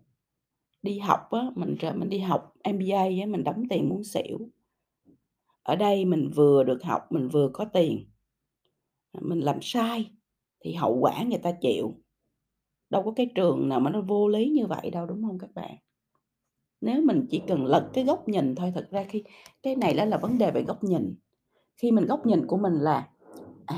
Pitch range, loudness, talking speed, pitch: 170-230 Hz, -26 LUFS, 200 wpm, 200 Hz